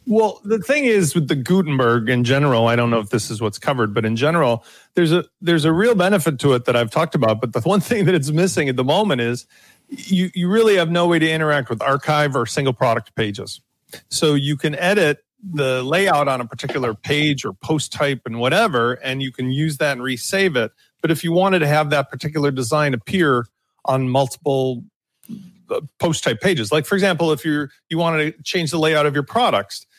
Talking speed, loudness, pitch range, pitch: 220 wpm, -19 LUFS, 130-175 Hz, 150 Hz